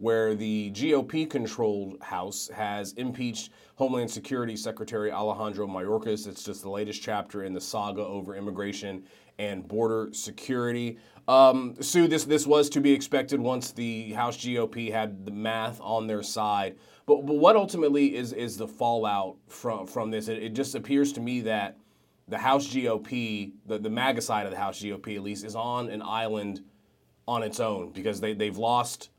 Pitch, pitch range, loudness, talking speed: 110 Hz, 105-125 Hz, -28 LUFS, 175 wpm